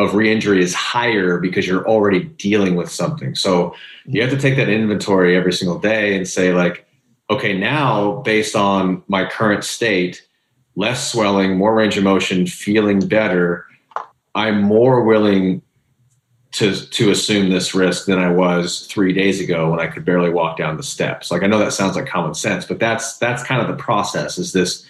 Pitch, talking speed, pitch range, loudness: 100 Hz, 185 wpm, 90-110 Hz, -17 LUFS